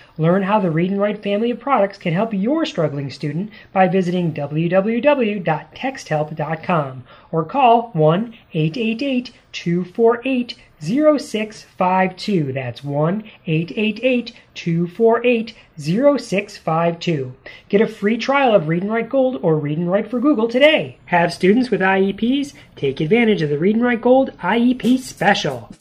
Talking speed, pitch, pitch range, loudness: 135 wpm, 200 Hz, 165-235 Hz, -18 LUFS